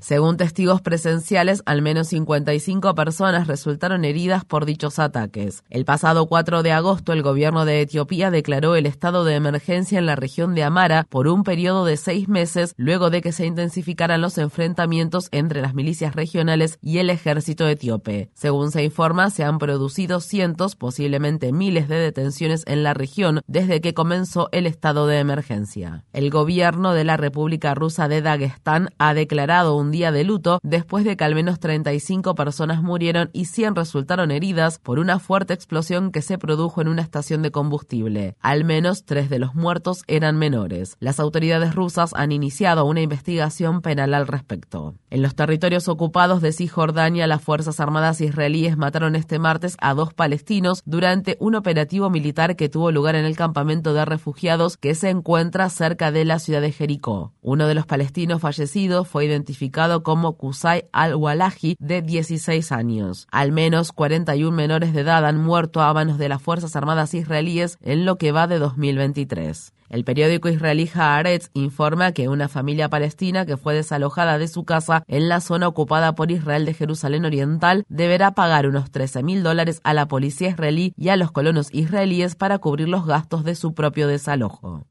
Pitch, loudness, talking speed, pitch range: 160 Hz, -20 LUFS, 175 wpm, 145-170 Hz